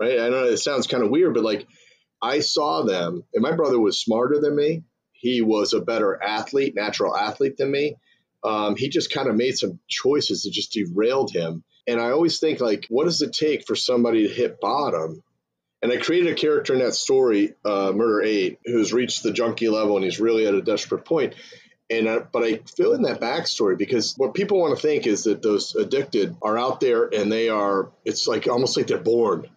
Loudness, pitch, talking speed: -22 LUFS, 135 Hz, 220 wpm